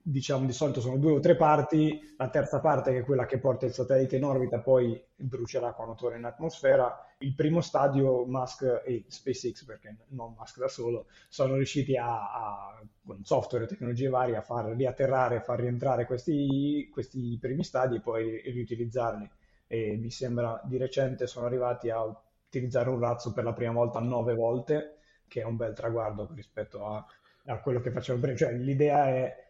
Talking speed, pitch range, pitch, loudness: 185 wpm, 120-135 Hz, 125 Hz, -30 LUFS